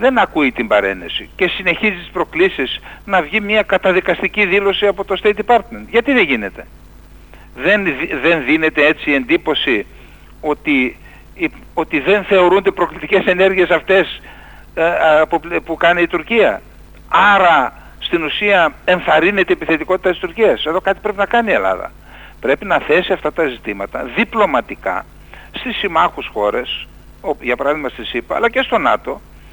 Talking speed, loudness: 150 wpm, -15 LUFS